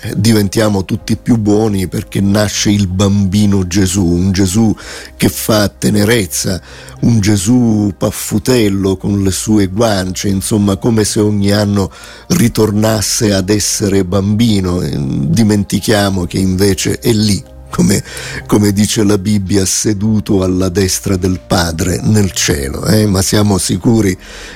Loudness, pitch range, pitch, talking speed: -12 LUFS, 95-105 Hz, 100 Hz, 125 wpm